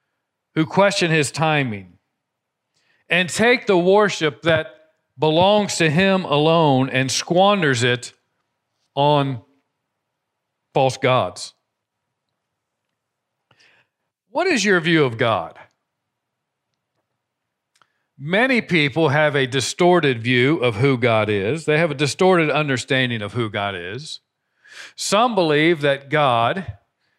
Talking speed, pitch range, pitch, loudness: 105 wpm, 130-175 Hz, 150 Hz, -18 LUFS